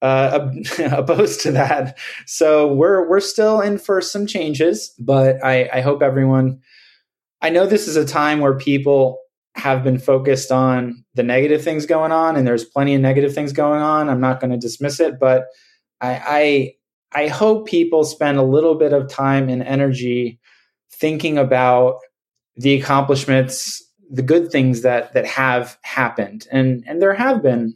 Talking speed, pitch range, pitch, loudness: 170 wpm, 130-155 Hz, 140 Hz, -17 LUFS